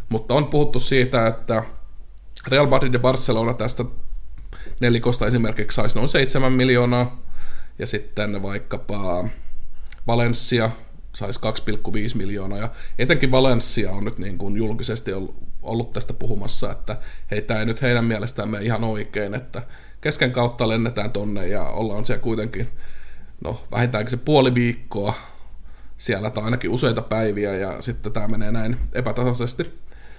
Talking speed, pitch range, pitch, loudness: 135 wpm, 105-125 Hz, 115 Hz, -22 LUFS